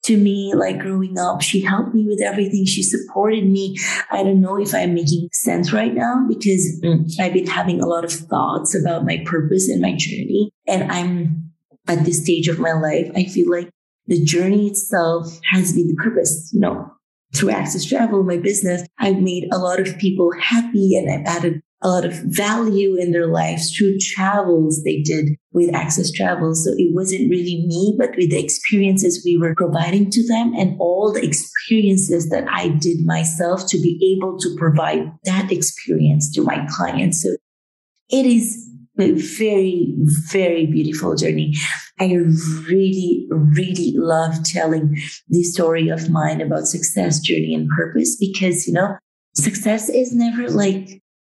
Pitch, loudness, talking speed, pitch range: 180 Hz, -18 LUFS, 170 wpm, 165-195 Hz